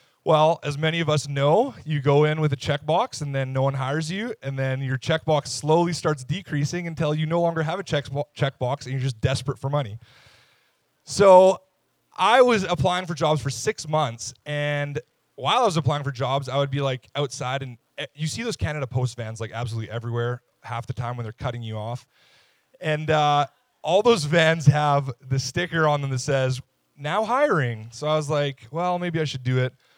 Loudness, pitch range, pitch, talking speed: -23 LUFS, 130-155 Hz, 145 Hz, 210 wpm